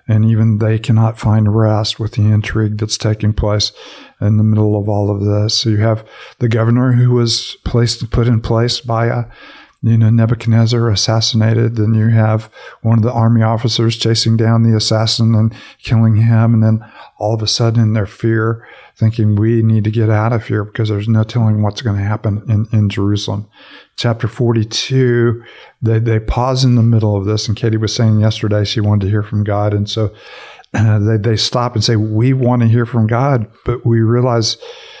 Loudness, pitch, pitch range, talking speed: -14 LUFS, 110 Hz, 110-115 Hz, 200 wpm